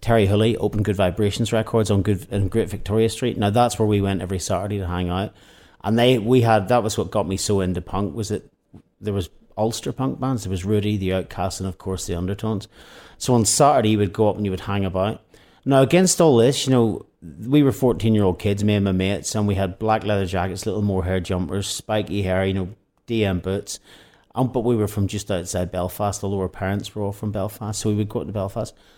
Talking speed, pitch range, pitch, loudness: 235 wpm, 95-110 Hz, 105 Hz, -21 LUFS